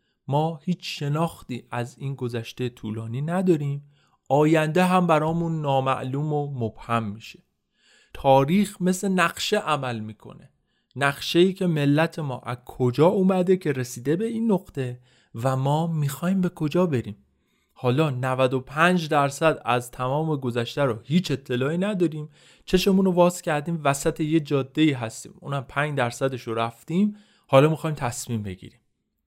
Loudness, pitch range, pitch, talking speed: -24 LUFS, 125-170 Hz, 145 Hz, 135 wpm